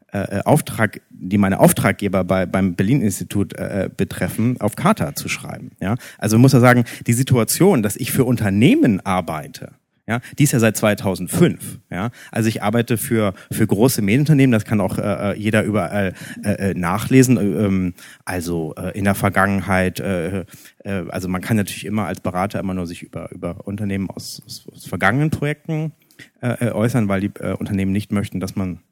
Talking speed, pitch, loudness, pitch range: 180 wpm, 105 Hz, -19 LUFS, 95-120 Hz